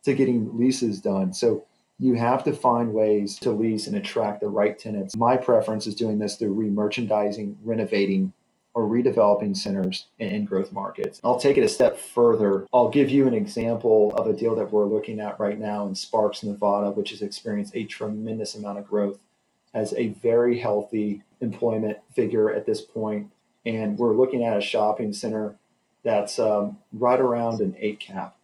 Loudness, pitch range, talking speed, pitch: -24 LUFS, 105-120 Hz, 180 wpm, 110 Hz